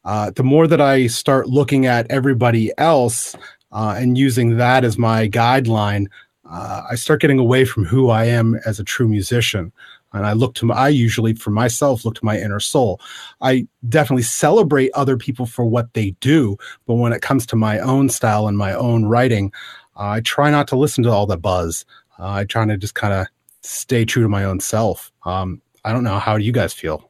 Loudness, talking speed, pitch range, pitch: -17 LUFS, 210 wpm, 105-130 Hz, 115 Hz